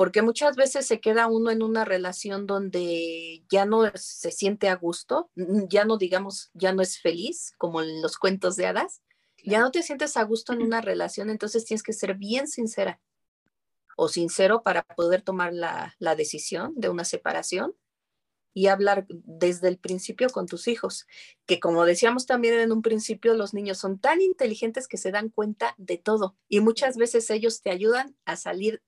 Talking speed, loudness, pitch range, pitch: 185 wpm, -25 LUFS, 185-230 Hz, 205 Hz